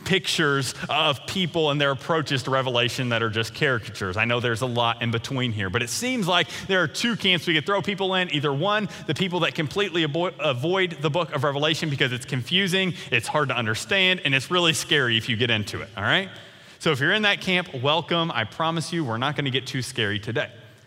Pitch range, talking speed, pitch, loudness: 125-180 Hz, 235 wpm, 150 Hz, -23 LUFS